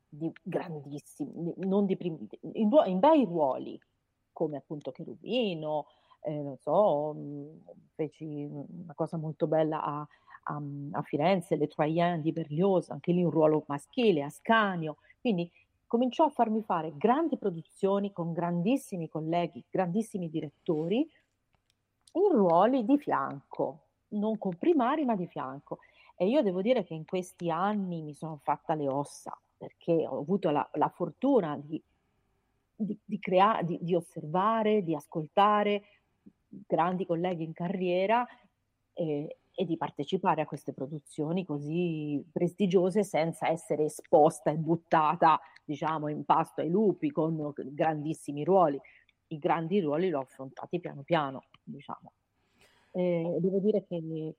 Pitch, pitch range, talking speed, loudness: 170 Hz, 155-195 Hz, 135 wpm, -30 LUFS